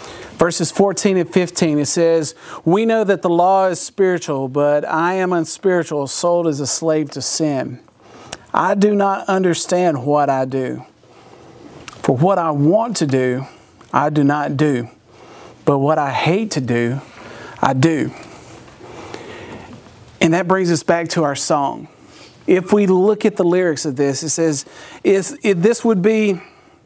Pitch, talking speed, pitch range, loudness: 165 Hz, 155 wpm, 145-190 Hz, -17 LUFS